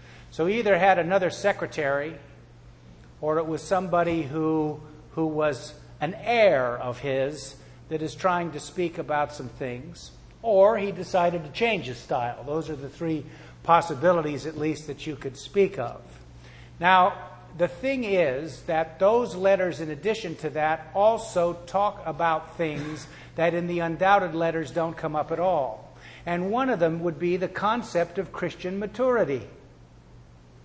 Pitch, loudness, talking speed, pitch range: 160 Hz, -26 LUFS, 155 wpm, 140-180 Hz